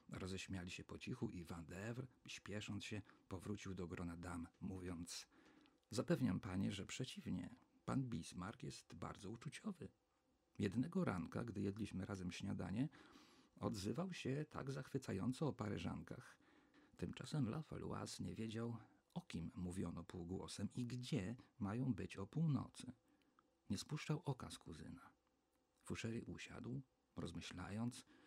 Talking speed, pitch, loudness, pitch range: 120 wpm, 105 Hz, -48 LUFS, 90-125 Hz